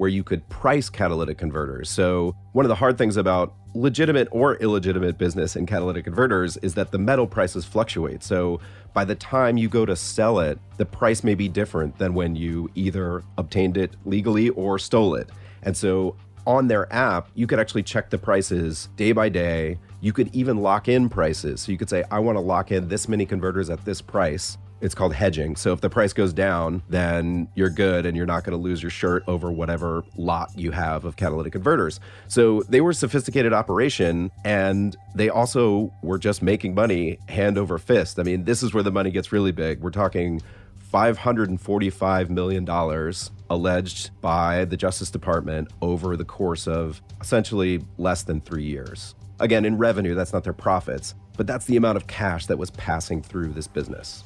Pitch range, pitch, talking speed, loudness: 90-105 Hz, 95 Hz, 195 wpm, -23 LUFS